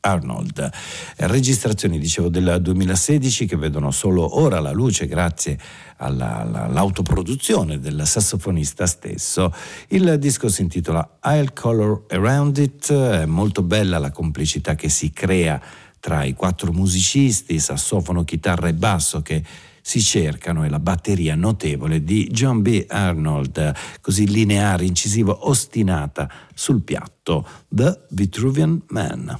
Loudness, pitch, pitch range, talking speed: -19 LUFS, 95 Hz, 80-110 Hz, 125 wpm